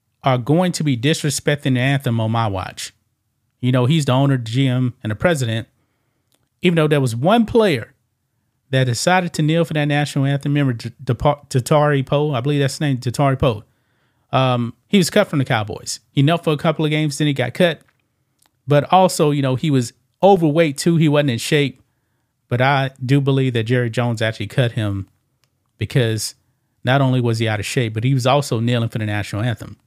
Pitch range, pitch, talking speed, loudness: 120-145 Hz, 130 Hz, 205 wpm, -18 LUFS